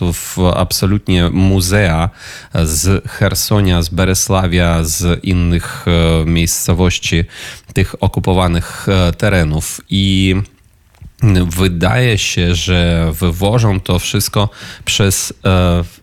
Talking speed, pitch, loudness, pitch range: 80 wpm, 95 Hz, -14 LUFS, 85-100 Hz